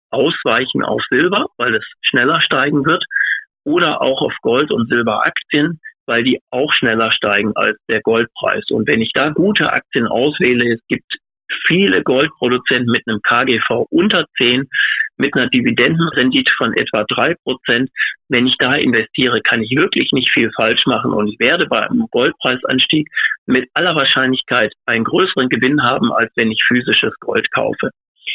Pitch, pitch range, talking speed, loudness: 130 Hz, 125-175 Hz, 160 wpm, -14 LUFS